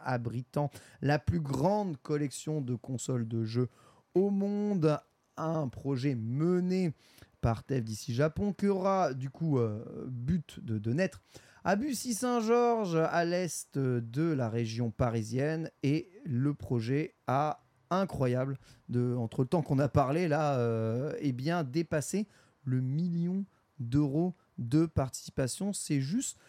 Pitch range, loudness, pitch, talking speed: 125-170 Hz, -32 LUFS, 145 Hz, 130 wpm